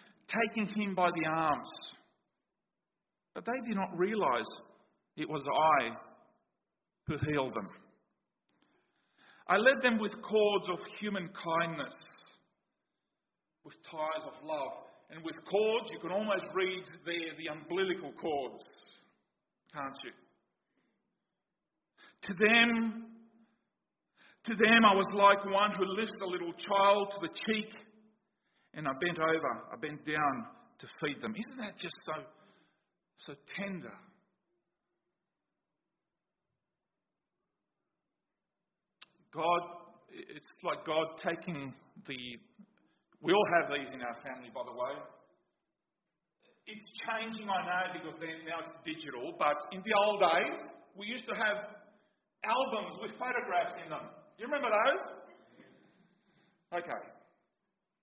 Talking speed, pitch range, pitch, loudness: 120 wpm, 170-215 Hz, 195 Hz, -33 LUFS